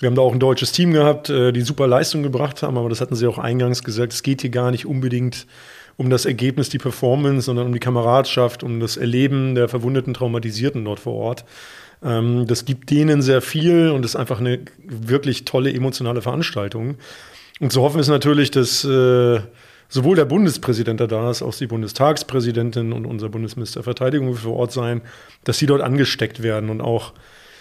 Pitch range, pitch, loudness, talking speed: 120-135 Hz, 125 Hz, -19 LUFS, 185 wpm